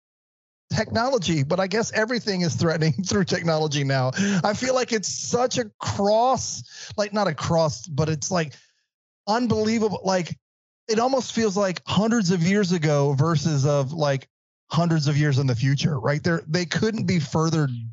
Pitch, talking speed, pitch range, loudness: 170 Hz, 165 wpm, 150-210 Hz, -23 LUFS